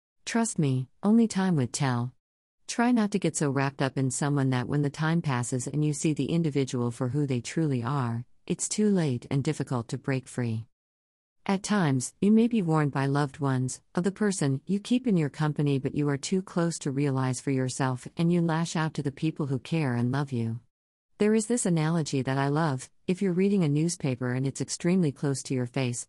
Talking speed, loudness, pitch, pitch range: 220 wpm, -28 LUFS, 145 Hz, 130-170 Hz